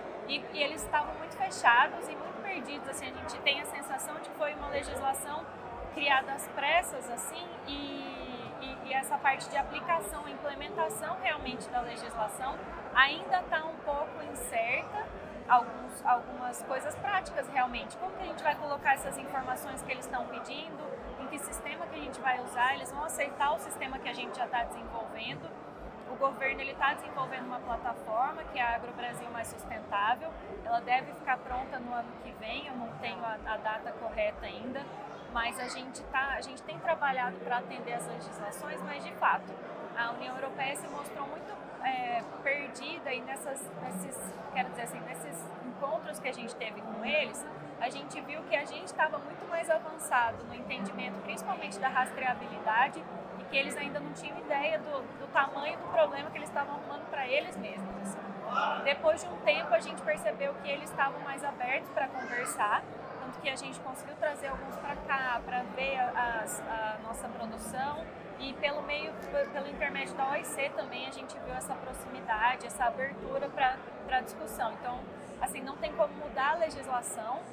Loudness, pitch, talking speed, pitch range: -34 LUFS, 275 Hz, 180 wpm, 245-305 Hz